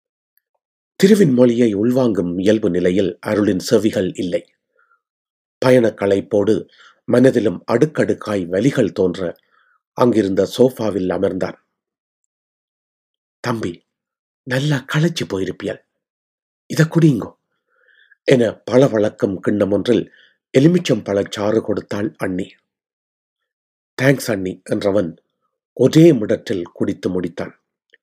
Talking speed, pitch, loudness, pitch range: 85 wpm, 125 Hz, -17 LUFS, 100-160 Hz